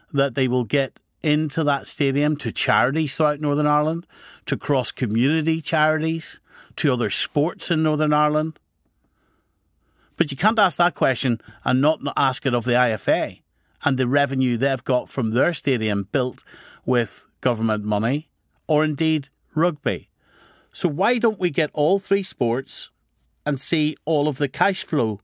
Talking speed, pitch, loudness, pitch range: 155 wpm, 145 Hz, -22 LUFS, 125-155 Hz